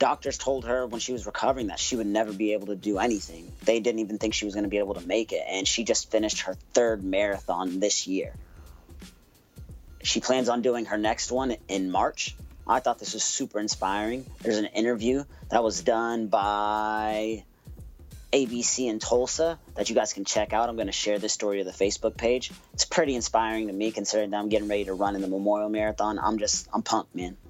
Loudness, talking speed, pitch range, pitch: -27 LUFS, 220 wpm, 100-115 Hz, 110 Hz